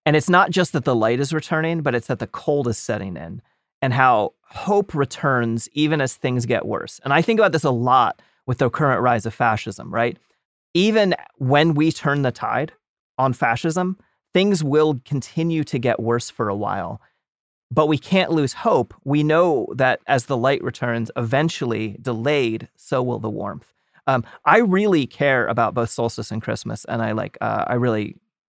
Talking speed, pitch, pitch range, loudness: 190 wpm, 135 Hz, 120-160 Hz, -20 LUFS